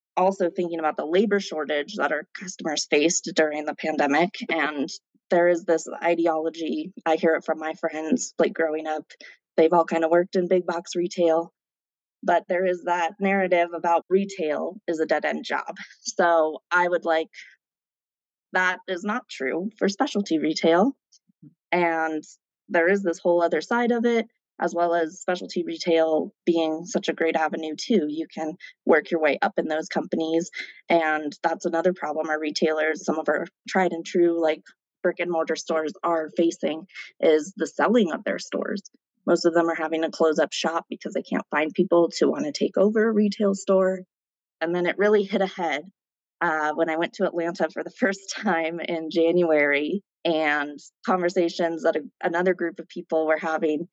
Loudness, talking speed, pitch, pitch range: -24 LUFS, 180 wpm, 170 Hz, 160-180 Hz